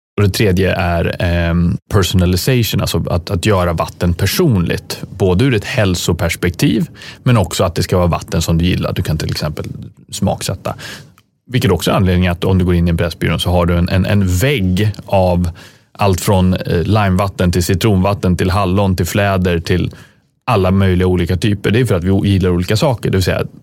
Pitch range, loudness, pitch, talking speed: 90-105 Hz, -15 LUFS, 95 Hz, 190 wpm